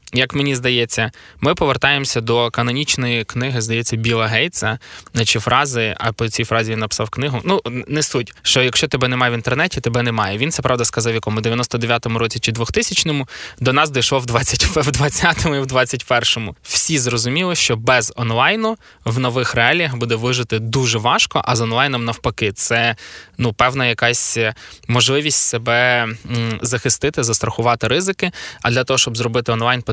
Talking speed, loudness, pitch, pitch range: 160 wpm, -16 LUFS, 120 Hz, 115-130 Hz